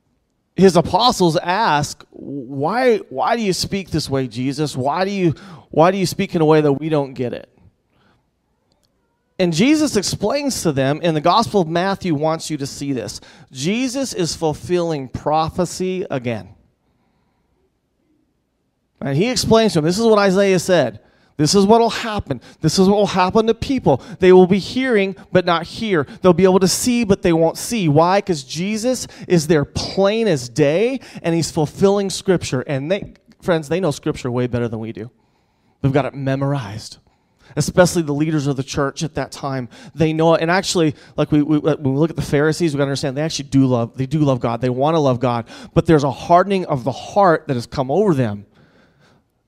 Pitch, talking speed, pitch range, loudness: 160 Hz, 200 wpm, 140-190 Hz, -18 LUFS